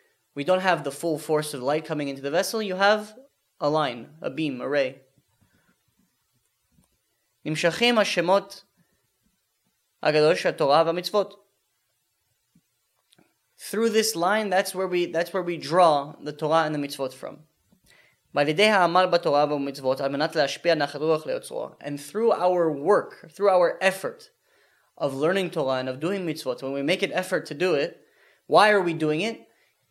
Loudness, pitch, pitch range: -24 LUFS, 170 Hz, 145-200 Hz